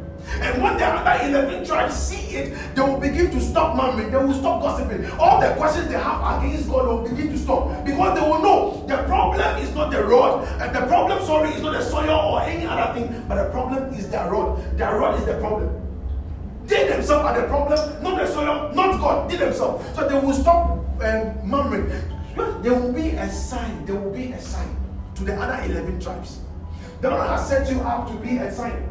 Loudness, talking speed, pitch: -21 LUFS, 215 wpm, 260 Hz